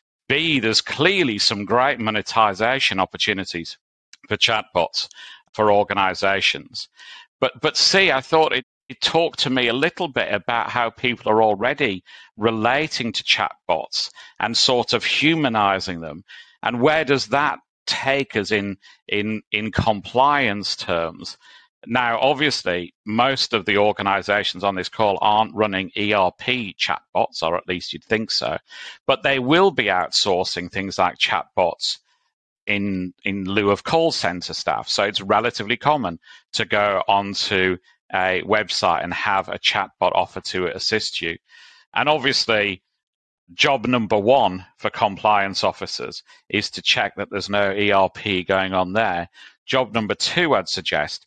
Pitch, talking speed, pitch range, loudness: 105 Hz, 145 wpm, 95-125 Hz, -20 LUFS